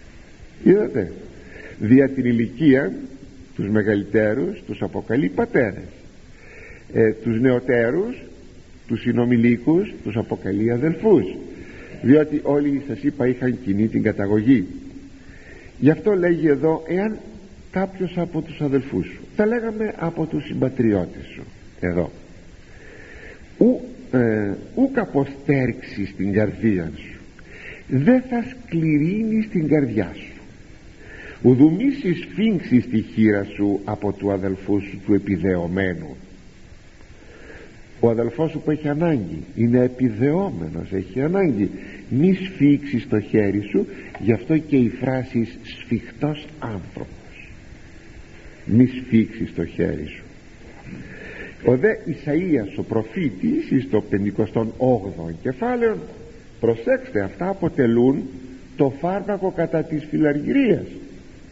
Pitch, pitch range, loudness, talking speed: 125 Hz, 105-155 Hz, -21 LUFS, 105 wpm